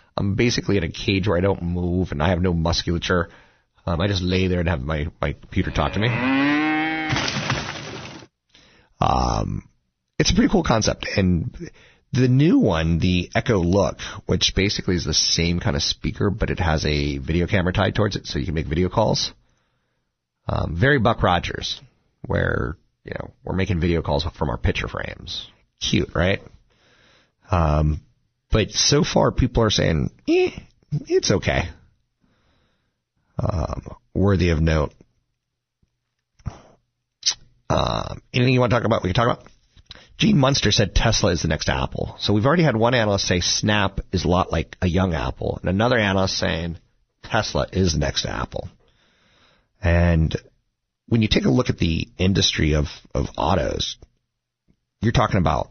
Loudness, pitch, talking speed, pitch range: -21 LUFS, 95 Hz, 165 wpm, 85-115 Hz